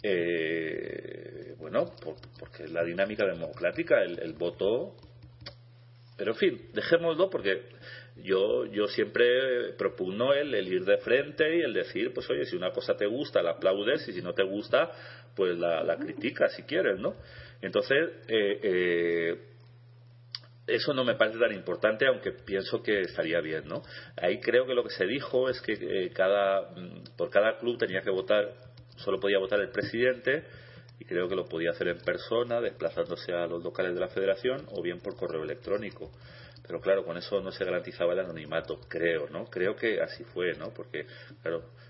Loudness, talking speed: -30 LUFS, 180 wpm